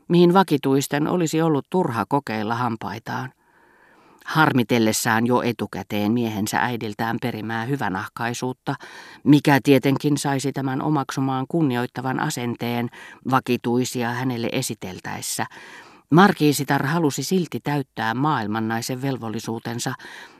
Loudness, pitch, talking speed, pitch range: -22 LUFS, 130 Hz, 90 wpm, 115-145 Hz